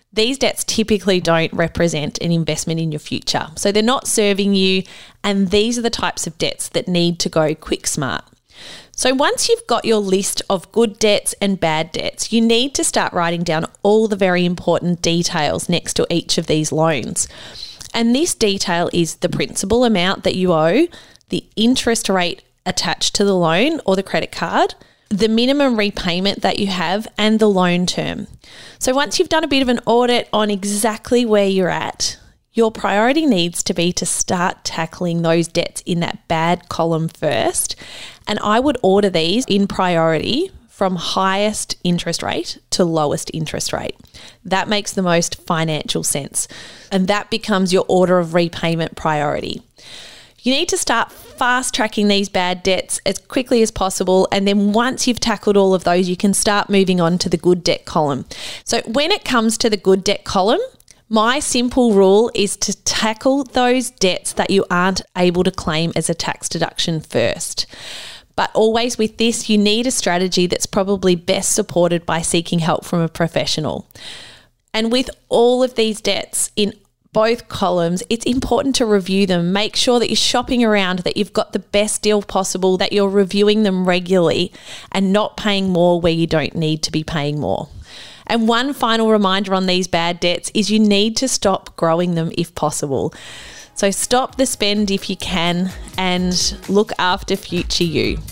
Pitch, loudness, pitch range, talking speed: 200 Hz, -17 LUFS, 175-225 Hz, 180 wpm